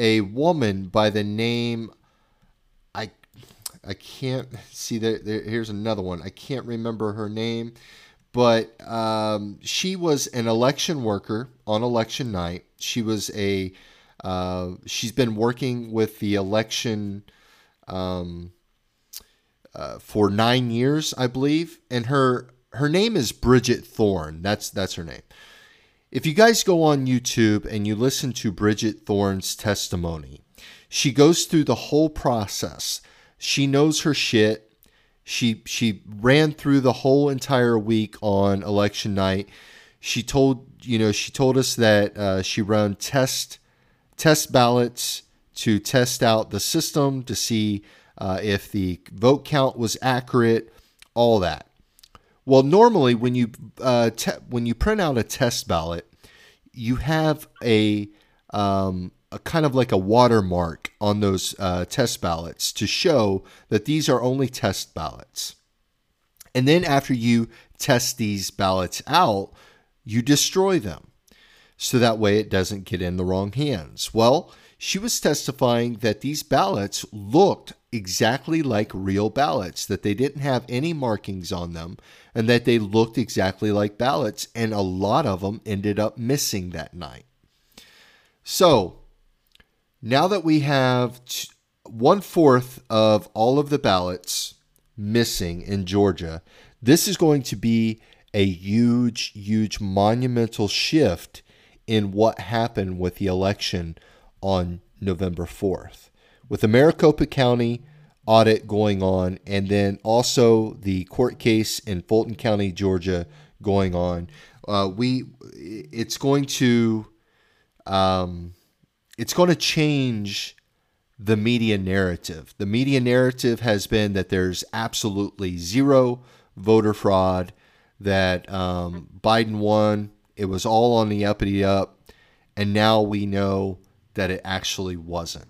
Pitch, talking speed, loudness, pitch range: 110 Hz, 135 wpm, -22 LUFS, 100-125 Hz